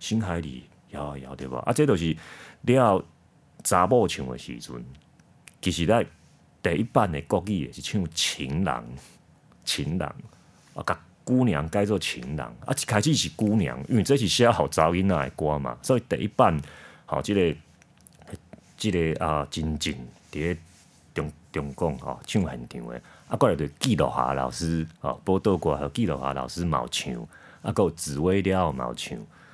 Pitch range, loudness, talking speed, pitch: 70-95 Hz, -26 LUFS, 245 characters per minute, 80 Hz